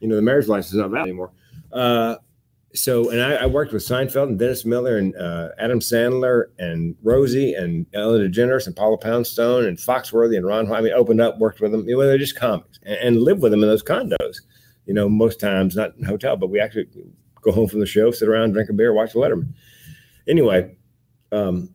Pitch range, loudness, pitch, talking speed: 105-125 Hz, -19 LUFS, 115 Hz, 230 wpm